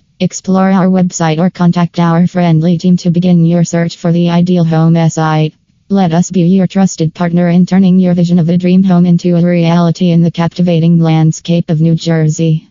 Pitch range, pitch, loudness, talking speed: 165-180 Hz, 175 Hz, -10 LUFS, 195 wpm